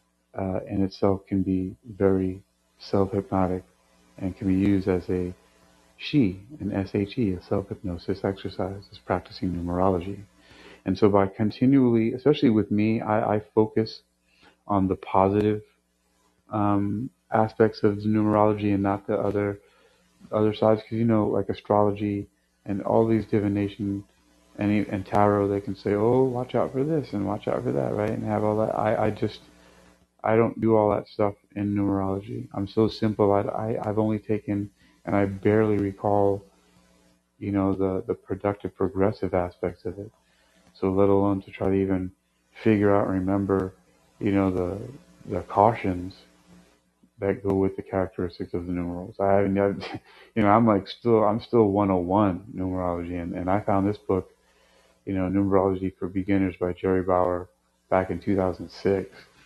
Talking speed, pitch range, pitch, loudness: 165 wpm, 90-105 Hz, 100 Hz, -25 LUFS